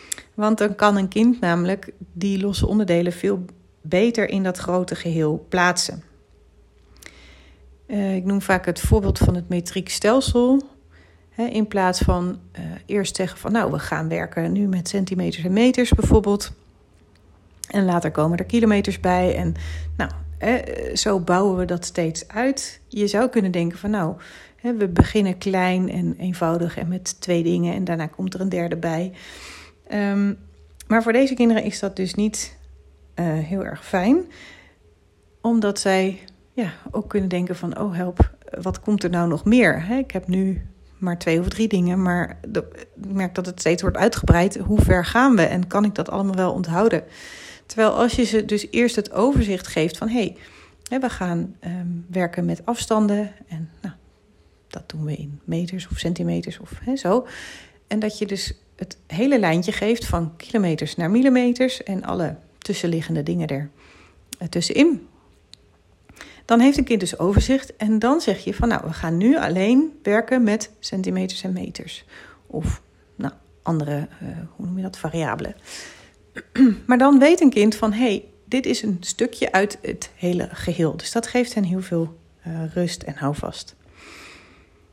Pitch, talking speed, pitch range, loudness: 185 Hz, 165 wpm, 170-215 Hz, -21 LUFS